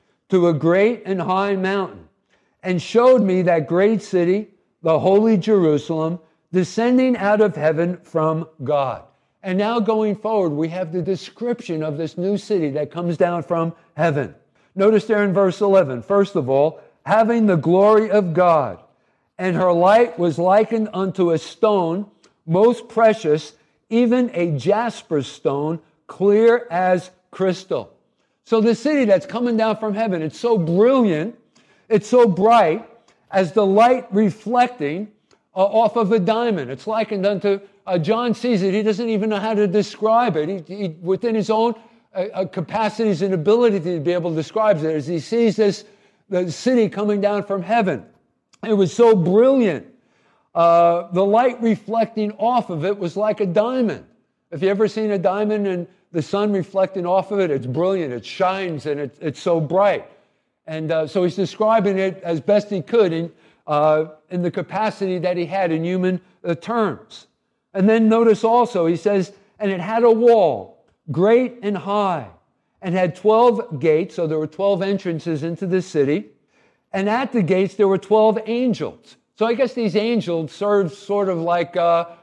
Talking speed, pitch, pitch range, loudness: 170 wpm, 195 Hz, 170-220 Hz, -19 LUFS